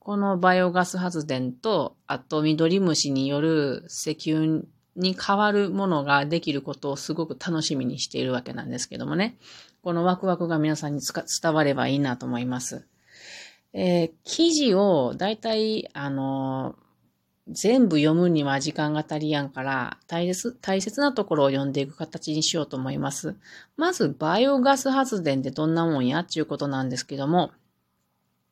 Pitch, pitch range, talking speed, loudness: 155 Hz, 140-180 Hz, 325 characters per minute, -25 LUFS